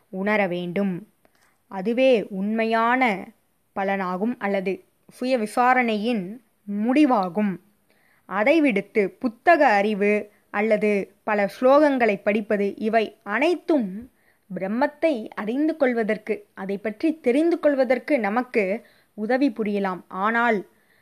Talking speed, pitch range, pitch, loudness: 85 wpm, 200-255 Hz, 215 Hz, -22 LUFS